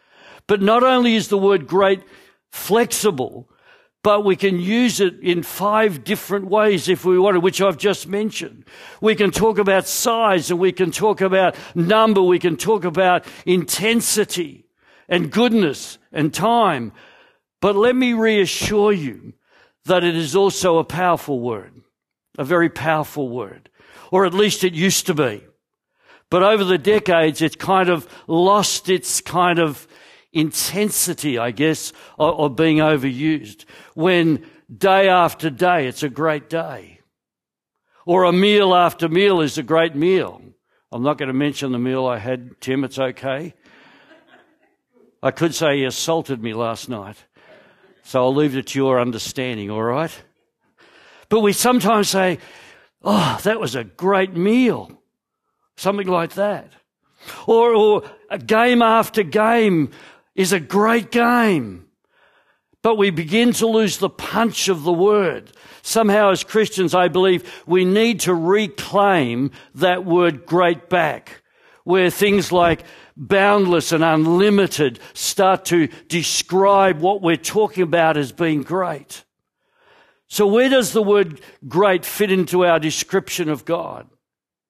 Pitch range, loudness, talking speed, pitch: 160-210 Hz, -18 LUFS, 145 wpm, 185 Hz